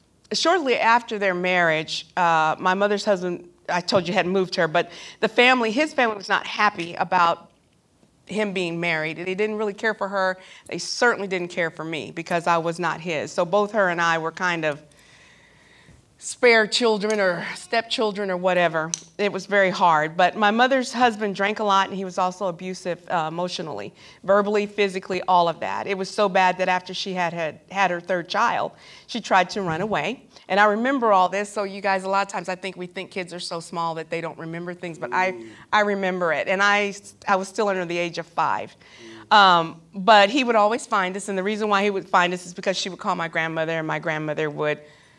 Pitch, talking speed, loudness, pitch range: 185 Hz, 220 wpm, -22 LUFS, 170-205 Hz